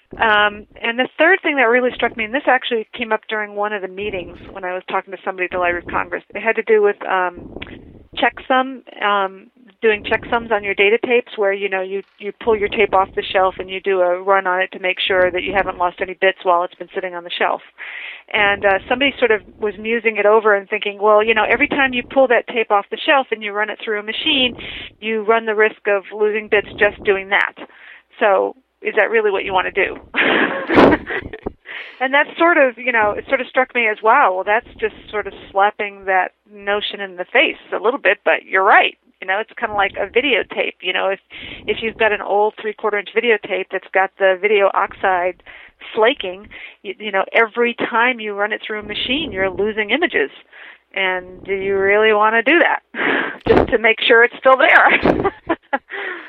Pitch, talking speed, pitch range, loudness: 210 Hz, 225 wpm, 195-235 Hz, -17 LUFS